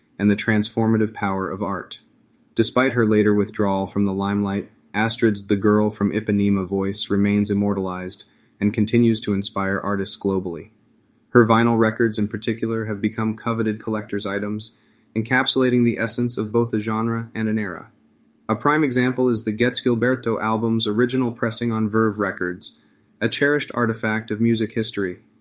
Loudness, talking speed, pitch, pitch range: -21 LUFS, 155 wpm, 110 Hz, 100-115 Hz